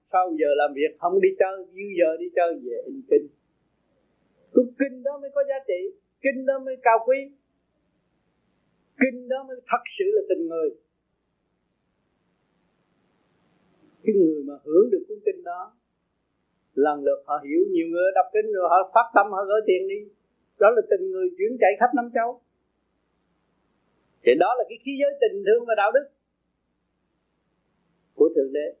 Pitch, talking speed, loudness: 270 Hz, 170 wpm, -23 LUFS